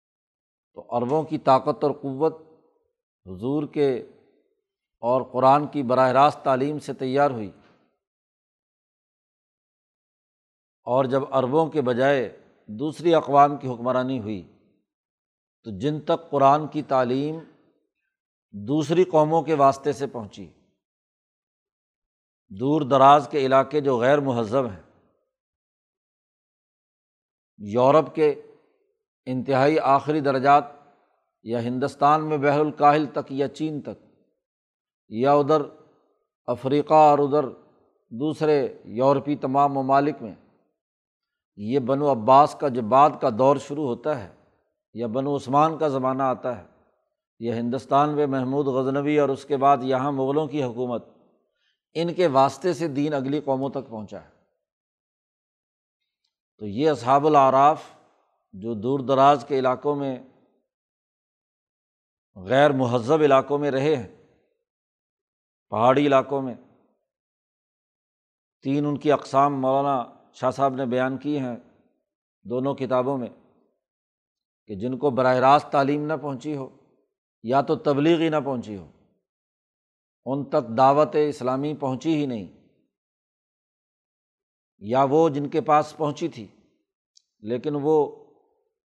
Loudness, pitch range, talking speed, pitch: -22 LUFS, 130-150 Hz, 120 wpm, 140 Hz